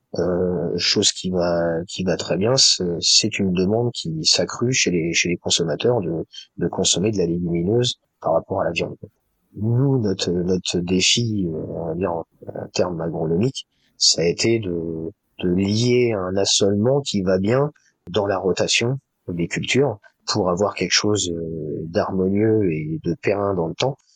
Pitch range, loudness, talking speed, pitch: 85-110 Hz, -20 LUFS, 165 wpm, 95 Hz